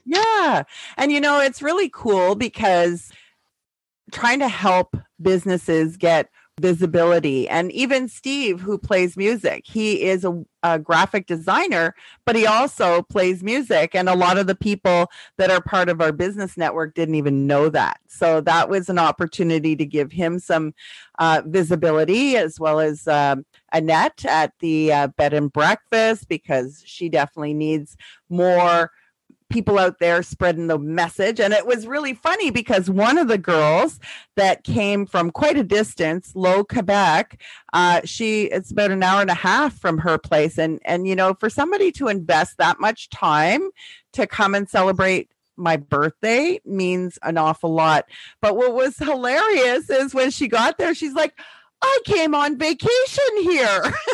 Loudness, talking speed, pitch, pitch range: -19 LUFS, 165 wpm, 185 Hz, 165-235 Hz